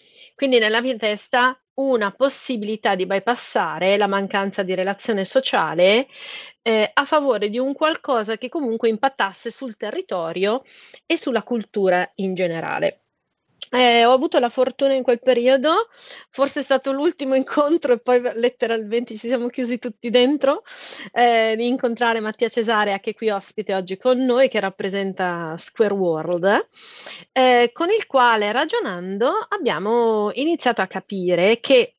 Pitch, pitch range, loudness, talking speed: 240 Hz, 210-270 Hz, -20 LUFS, 145 wpm